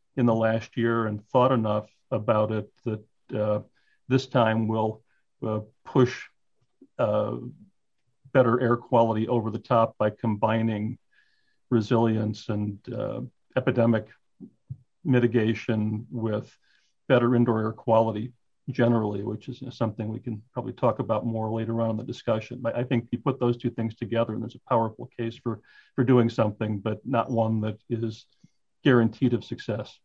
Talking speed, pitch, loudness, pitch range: 155 wpm, 115 Hz, -26 LUFS, 110-125 Hz